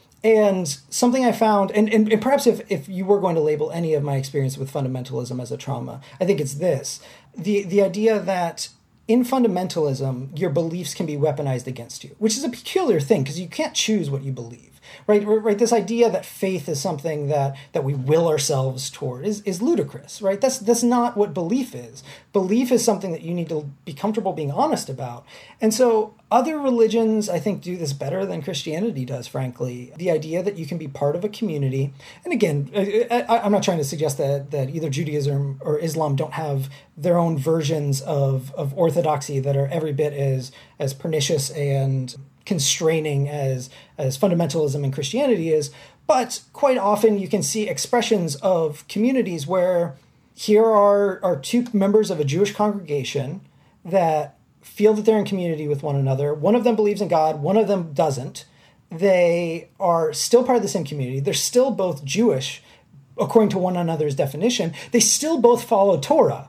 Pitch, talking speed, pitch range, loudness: 170 Hz, 190 wpm, 145-210 Hz, -21 LUFS